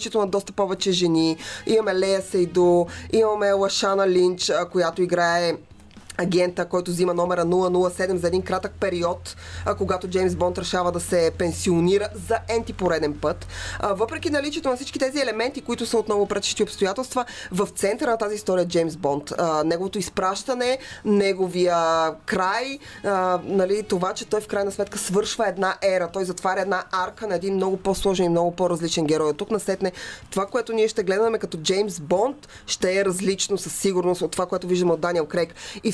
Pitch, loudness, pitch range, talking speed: 190 Hz, -23 LUFS, 175-205 Hz, 170 wpm